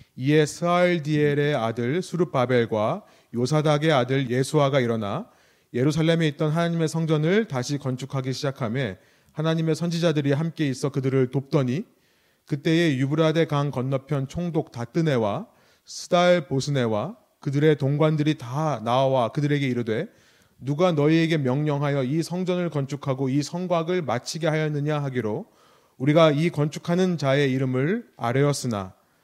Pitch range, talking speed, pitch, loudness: 130-160 Hz, 330 characters per minute, 145 Hz, -24 LUFS